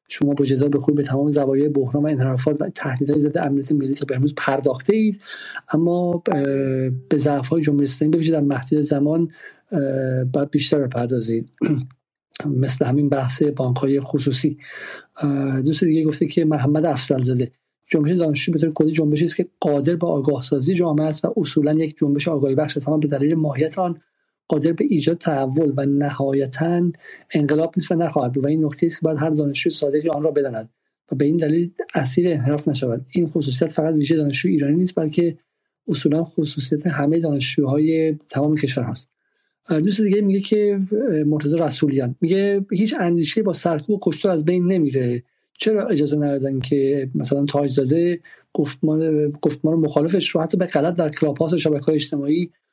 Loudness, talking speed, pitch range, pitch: -20 LUFS, 170 wpm, 140-165 Hz, 150 Hz